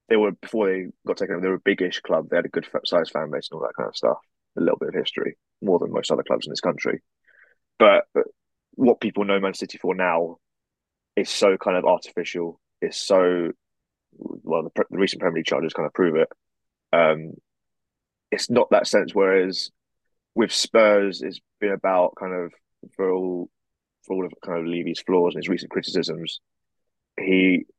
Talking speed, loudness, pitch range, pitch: 195 wpm, -23 LUFS, 90-105 Hz, 95 Hz